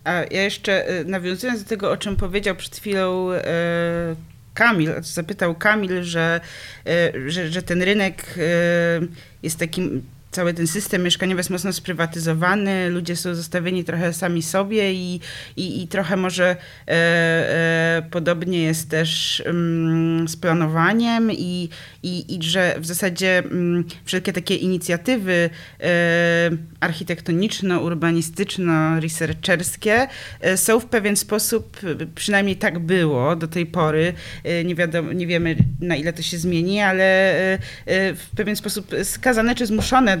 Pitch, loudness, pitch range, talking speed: 175 Hz, -20 LUFS, 165-190 Hz, 140 wpm